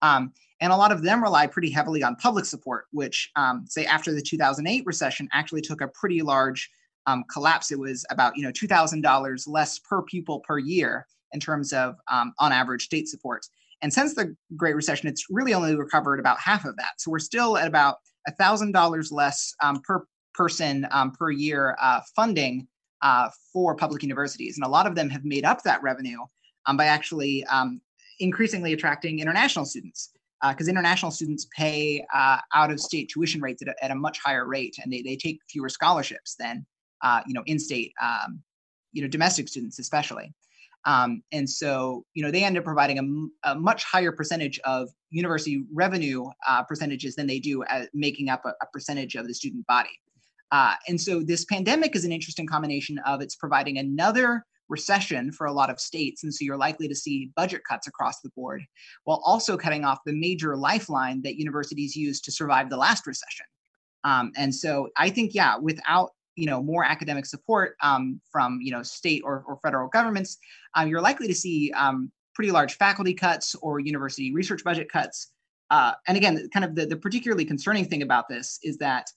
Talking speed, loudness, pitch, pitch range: 195 wpm, -25 LUFS, 150 Hz, 140-175 Hz